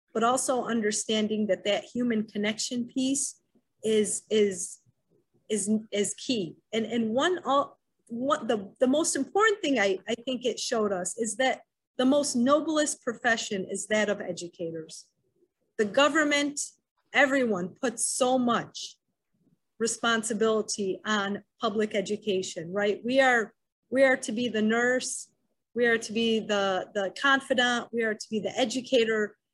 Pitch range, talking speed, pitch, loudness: 210-260 Hz, 145 wpm, 230 Hz, -27 LUFS